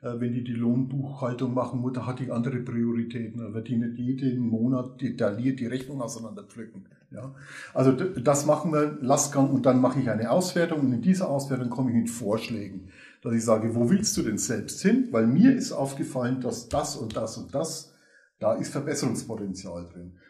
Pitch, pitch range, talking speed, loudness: 125 Hz, 115-140 Hz, 185 wpm, -26 LUFS